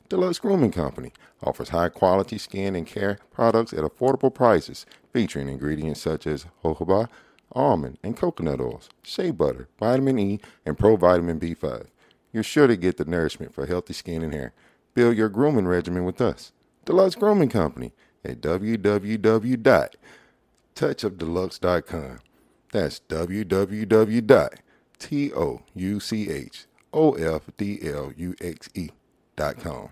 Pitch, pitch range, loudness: 100 Hz, 85-115 Hz, -24 LUFS